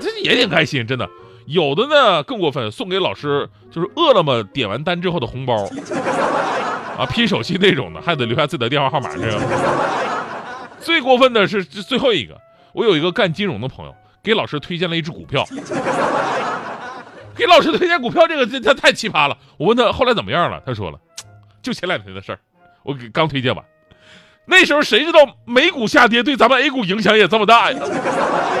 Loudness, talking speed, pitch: -16 LUFS, 300 characters per minute, 180 Hz